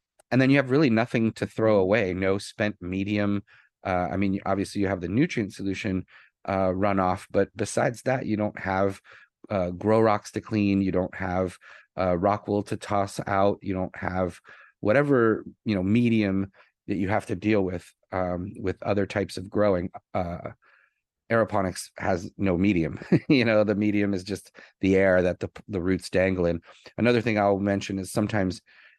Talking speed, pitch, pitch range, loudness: 180 wpm, 100 Hz, 95-105 Hz, -26 LUFS